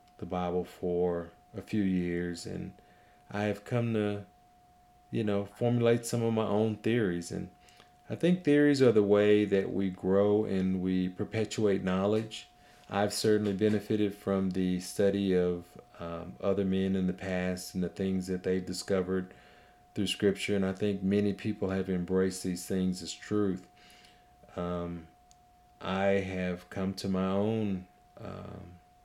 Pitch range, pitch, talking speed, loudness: 90-105 Hz, 95 Hz, 150 wpm, -31 LUFS